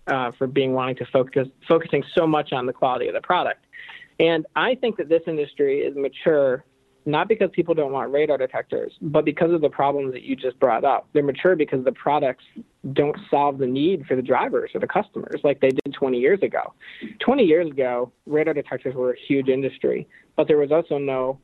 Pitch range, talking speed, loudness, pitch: 135-180 Hz, 210 wpm, -22 LUFS, 150 Hz